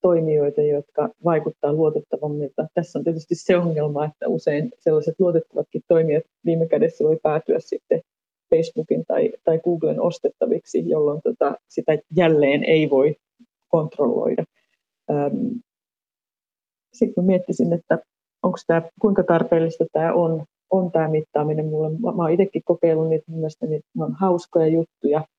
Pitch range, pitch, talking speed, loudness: 155-185 Hz, 165 Hz, 125 wpm, -21 LUFS